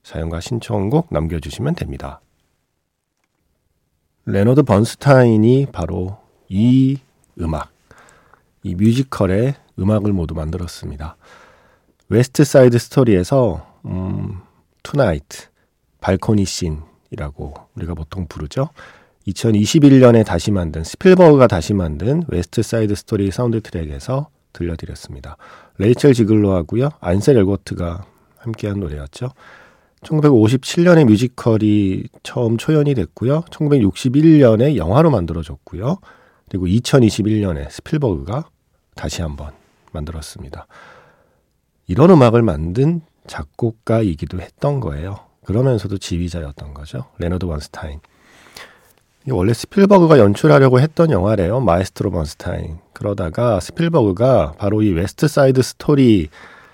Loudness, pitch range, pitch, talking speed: -16 LUFS, 85-130 Hz, 105 Hz, 280 characters per minute